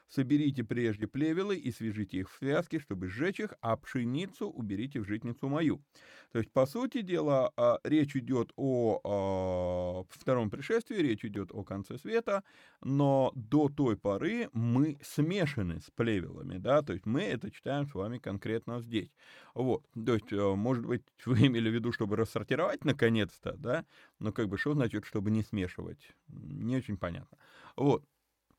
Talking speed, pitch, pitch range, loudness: 155 wpm, 120 Hz, 105-140 Hz, -33 LUFS